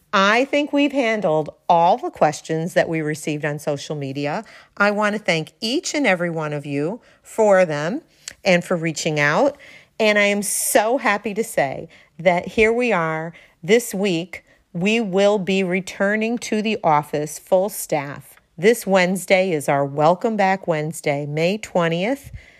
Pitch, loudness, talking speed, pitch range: 185 Hz, -20 LUFS, 160 wpm, 155-220 Hz